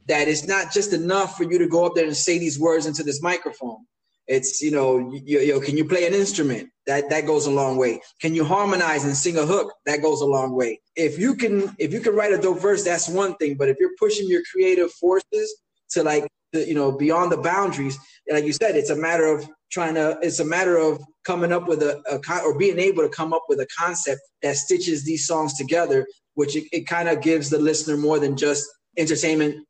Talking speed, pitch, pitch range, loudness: 240 wpm, 160 Hz, 150-185 Hz, -22 LUFS